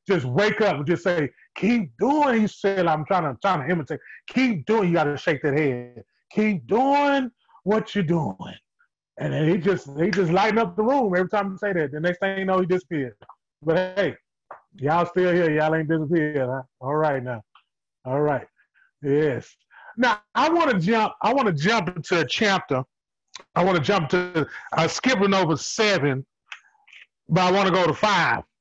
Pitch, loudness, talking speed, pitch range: 180 Hz, -22 LUFS, 195 wpm, 155-205 Hz